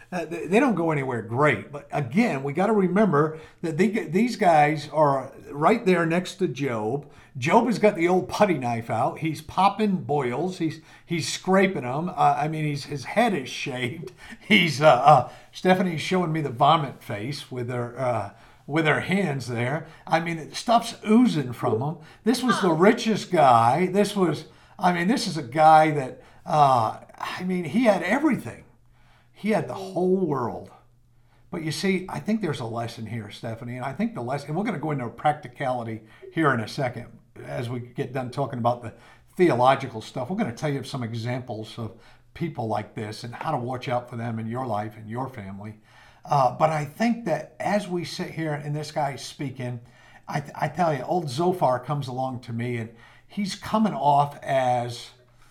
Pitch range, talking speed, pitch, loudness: 120-180 Hz, 195 wpm, 145 Hz, -24 LUFS